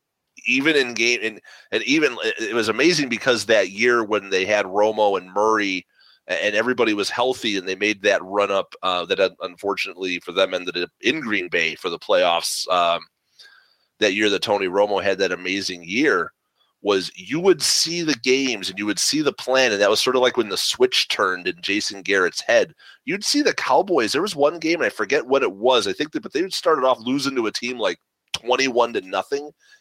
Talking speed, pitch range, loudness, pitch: 215 wpm, 105-170 Hz, -20 LUFS, 125 Hz